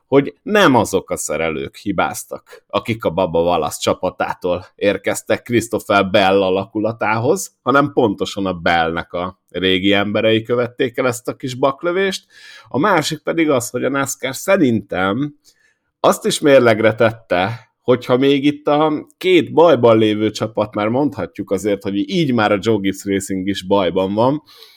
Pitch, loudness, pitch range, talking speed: 120 Hz, -17 LUFS, 100-145 Hz, 145 wpm